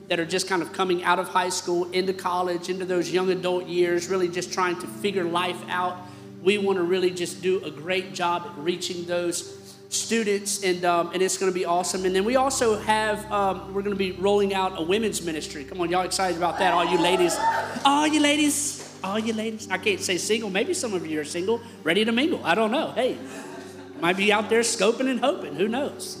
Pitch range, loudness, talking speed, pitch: 175-205 Hz, -24 LUFS, 230 wpm, 185 Hz